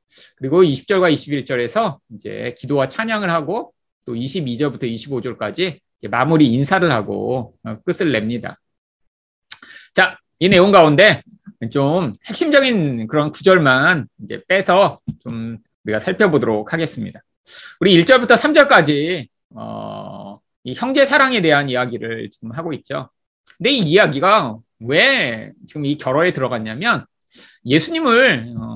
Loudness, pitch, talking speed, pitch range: -16 LUFS, 145 Hz, 265 characters per minute, 120-185 Hz